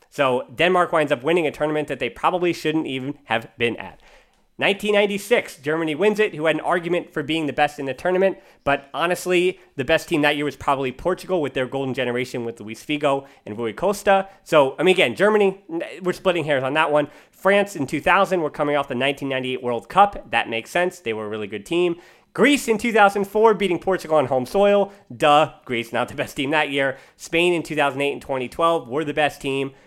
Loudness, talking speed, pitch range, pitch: -21 LUFS, 210 wpm, 135-180 Hz, 155 Hz